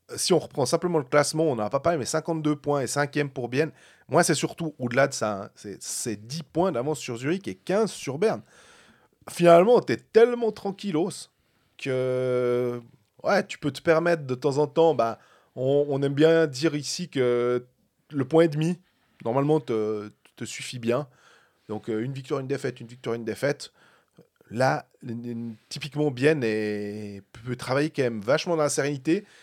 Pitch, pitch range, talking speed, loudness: 140 Hz, 120-160 Hz, 190 wpm, -25 LUFS